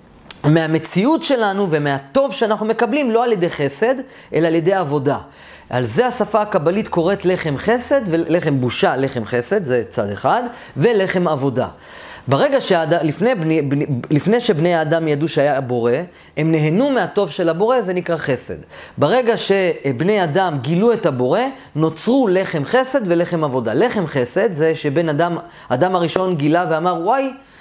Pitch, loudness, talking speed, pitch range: 170 Hz, -17 LUFS, 145 wpm, 150-215 Hz